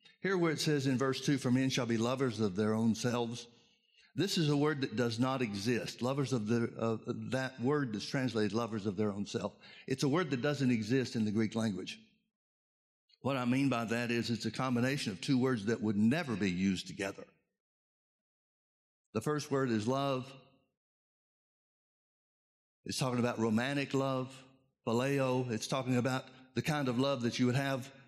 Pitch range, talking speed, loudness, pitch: 115-135 Hz, 185 wpm, -34 LUFS, 125 Hz